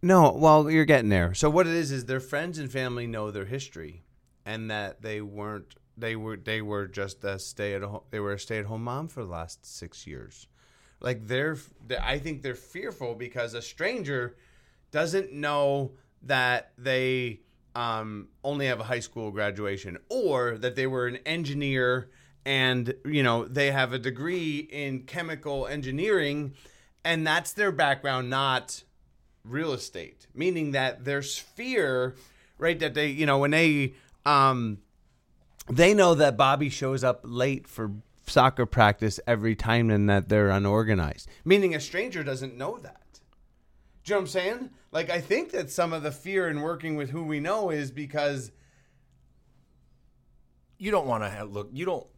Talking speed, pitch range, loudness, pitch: 165 wpm, 110-150 Hz, -27 LUFS, 130 Hz